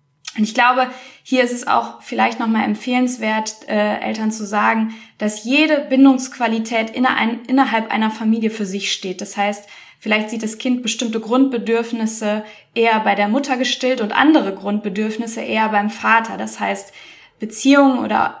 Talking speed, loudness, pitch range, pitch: 155 wpm, -18 LUFS, 210-250 Hz, 225 Hz